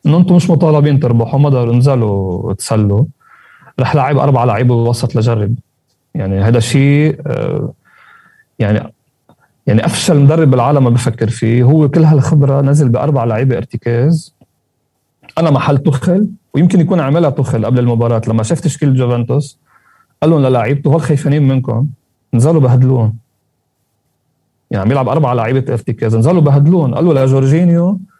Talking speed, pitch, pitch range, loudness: 135 wpm, 135 Hz, 120-155 Hz, -12 LUFS